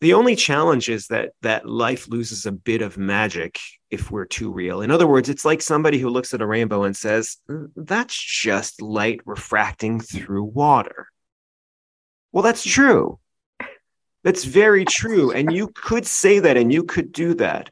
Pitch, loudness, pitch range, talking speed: 125 Hz, -19 LUFS, 110-170 Hz, 175 wpm